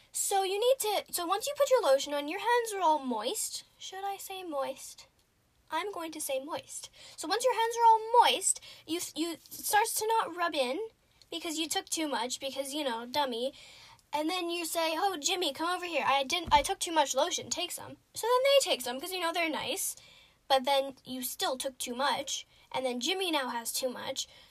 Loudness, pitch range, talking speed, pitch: -31 LUFS, 275-390 Hz, 220 wpm, 325 Hz